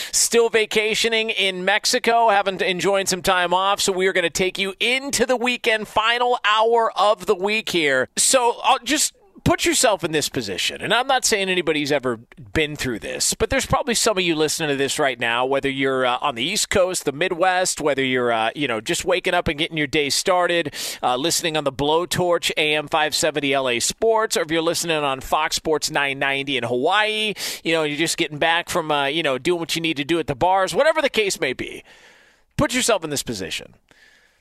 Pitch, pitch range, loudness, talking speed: 175 Hz, 150-215 Hz, -20 LUFS, 215 wpm